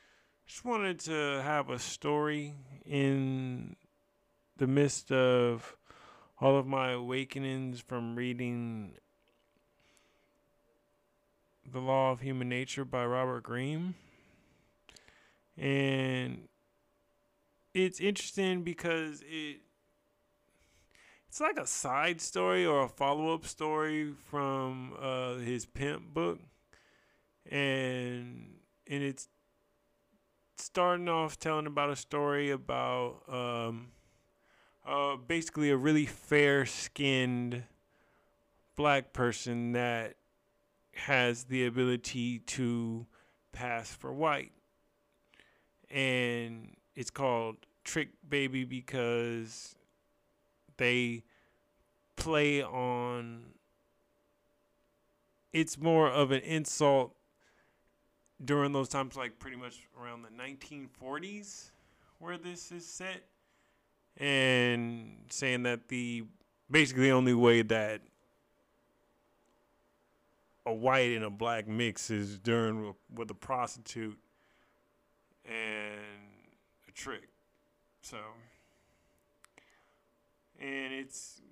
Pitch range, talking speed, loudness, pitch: 120-145 Hz, 90 wpm, -33 LUFS, 130 Hz